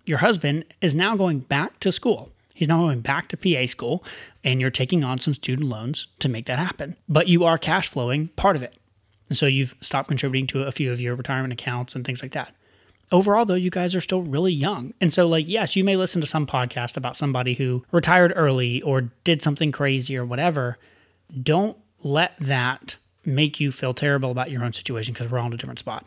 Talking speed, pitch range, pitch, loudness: 225 wpm, 125-170 Hz, 140 Hz, -23 LUFS